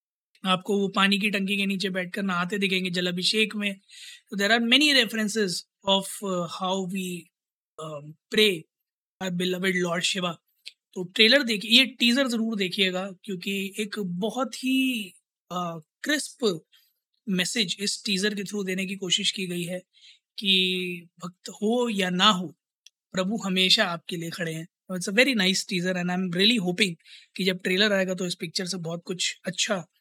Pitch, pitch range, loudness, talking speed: 195 Hz, 180-215 Hz, -24 LUFS, 150 wpm